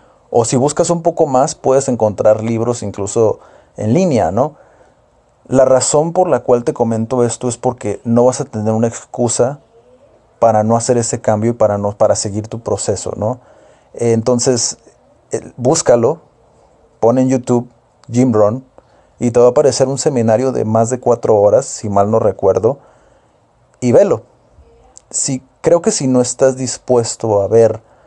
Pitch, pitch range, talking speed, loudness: 120 Hz, 115-130 Hz, 160 wpm, -14 LUFS